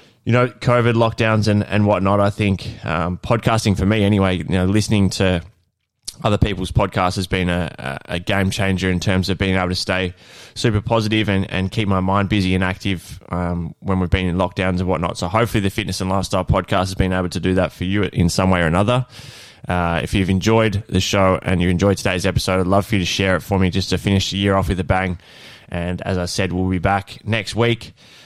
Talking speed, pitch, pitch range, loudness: 235 wpm, 95 Hz, 90-105 Hz, -19 LUFS